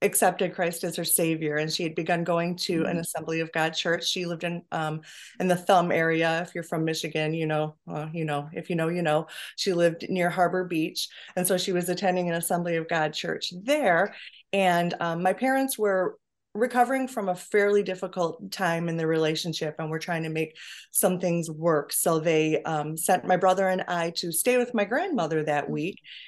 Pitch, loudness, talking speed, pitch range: 175 Hz, -26 LUFS, 210 wpm, 160-185 Hz